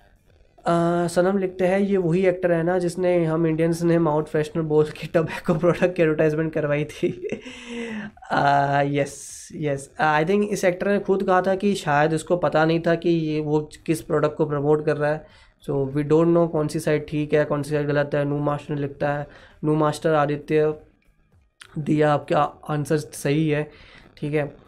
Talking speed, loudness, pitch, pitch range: 195 wpm, -22 LUFS, 155 Hz, 150-175 Hz